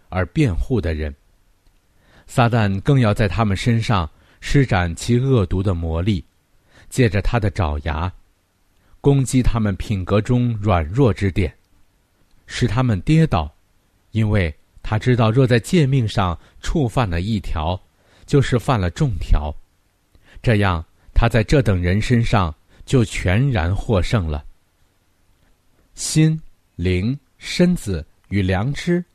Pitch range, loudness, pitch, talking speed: 90-120 Hz, -19 LUFS, 100 Hz, 180 characters per minute